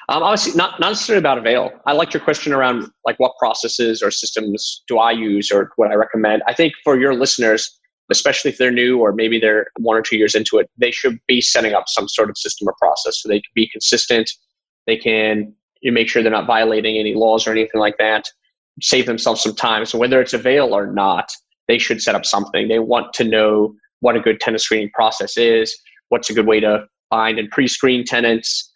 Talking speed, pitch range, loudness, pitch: 225 wpm, 110-125 Hz, -16 LUFS, 115 Hz